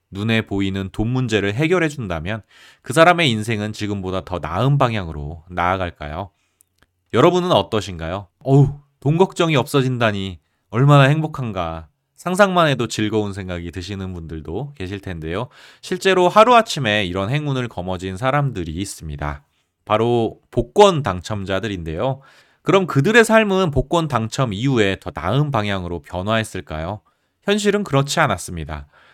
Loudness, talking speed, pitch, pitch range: -19 LUFS, 330 characters per minute, 110 Hz, 95-140 Hz